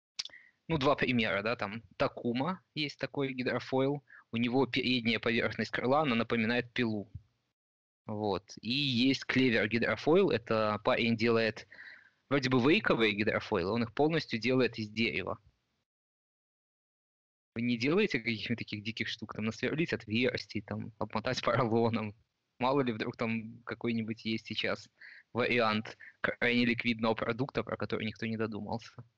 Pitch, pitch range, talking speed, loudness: 115 Hz, 110-125 Hz, 130 wpm, -32 LUFS